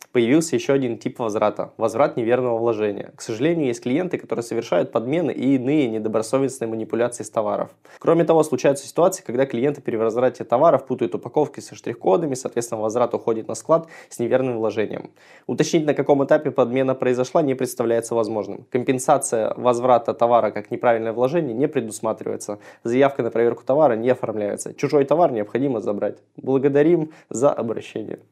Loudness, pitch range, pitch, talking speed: -21 LUFS, 115-140 Hz, 125 Hz, 155 wpm